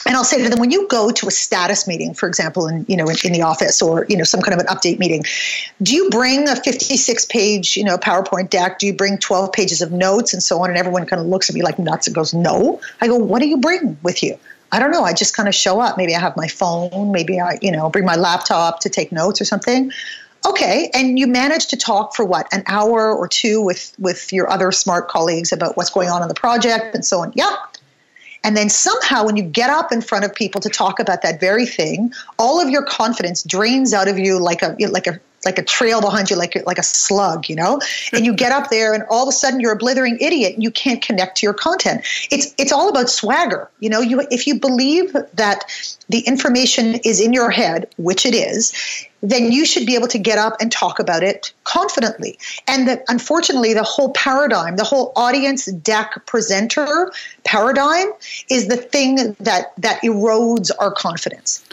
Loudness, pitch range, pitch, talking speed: -16 LUFS, 190-255 Hz, 220 Hz, 235 wpm